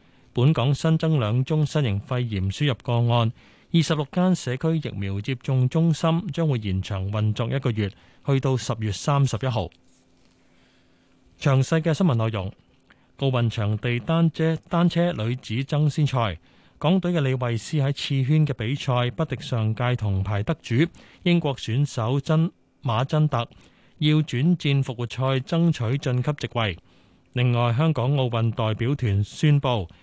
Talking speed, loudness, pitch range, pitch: 230 characters per minute, -24 LUFS, 115-155 Hz, 130 Hz